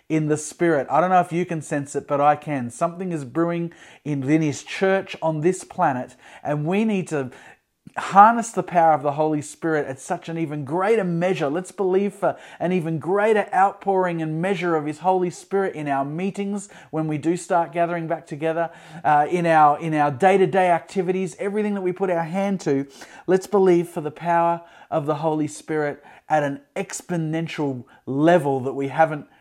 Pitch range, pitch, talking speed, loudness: 150-185 Hz, 170 Hz, 190 wpm, -22 LUFS